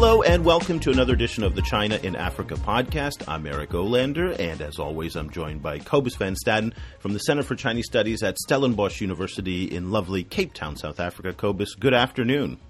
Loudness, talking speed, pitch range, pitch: -24 LUFS, 200 wpm, 85-125 Hz, 100 Hz